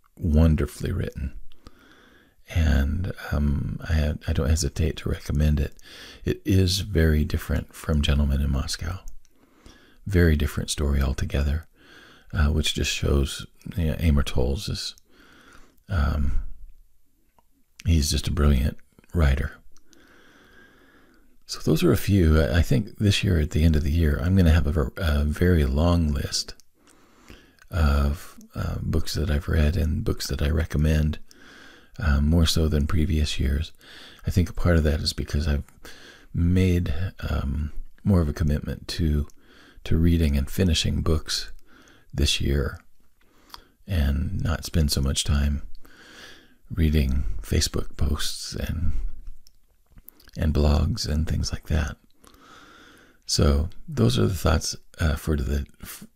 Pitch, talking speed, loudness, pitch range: 80 Hz, 135 wpm, -25 LUFS, 75-85 Hz